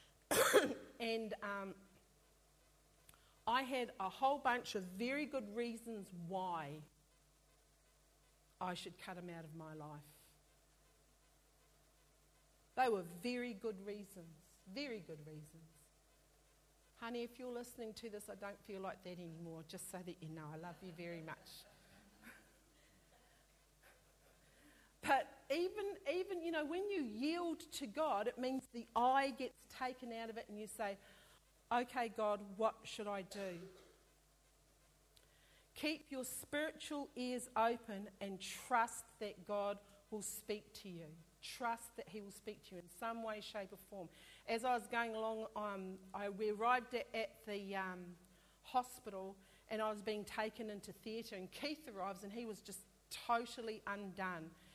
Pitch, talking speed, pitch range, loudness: 210 Hz, 145 wpm, 185-240 Hz, -43 LUFS